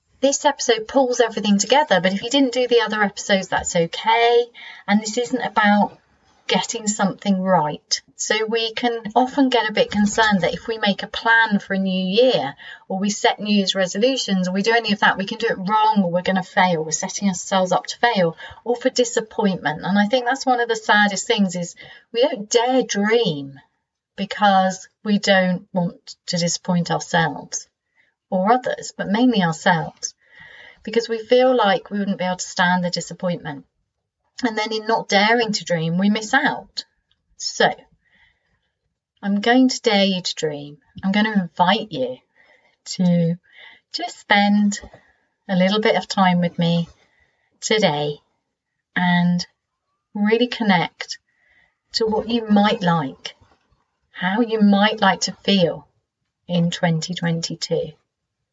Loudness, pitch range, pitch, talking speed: -19 LUFS, 180-235 Hz, 205 Hz, 160 wpm